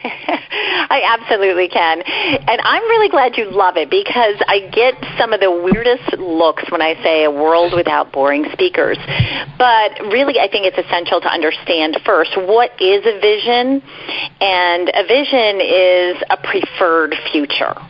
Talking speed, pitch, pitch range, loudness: 155 wpm, 190 Hz, 170-275 Hz, -14 LUFS